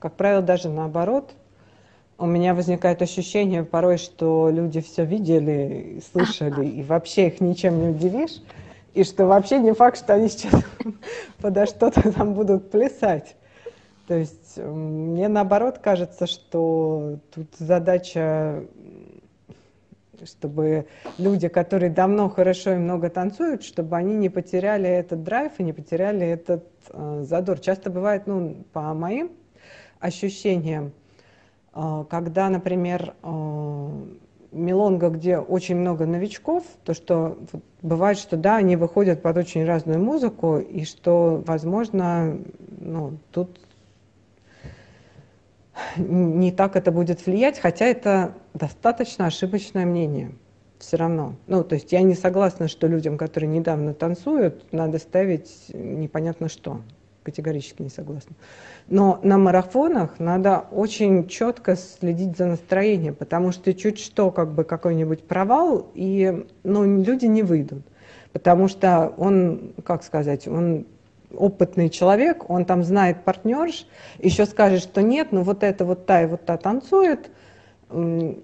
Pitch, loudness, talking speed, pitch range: 180 Hz, -22 LUFS, 130 wpm, 160-195 Hz